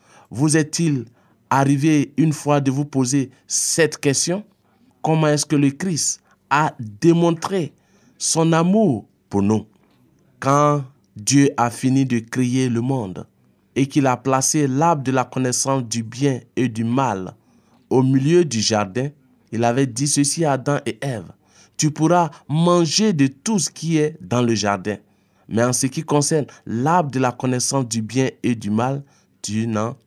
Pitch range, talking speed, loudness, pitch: 120-150 Hz, 160 wpm, -19 LUFS, 135 Hz